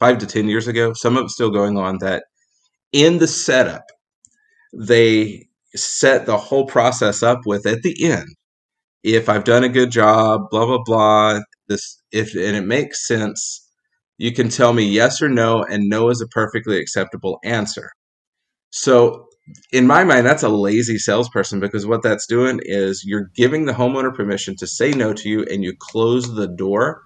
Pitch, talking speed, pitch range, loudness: 115 Hz, 180 wpm, 105-125 Hz, -17 LUFS